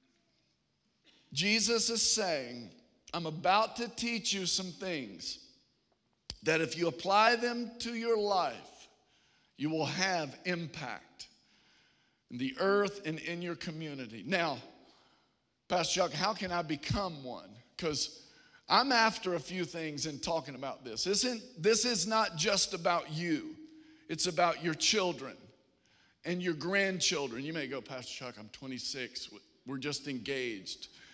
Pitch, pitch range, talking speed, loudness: 175 Hz, 150-210 Hz, 140 wpm, -33 LUFS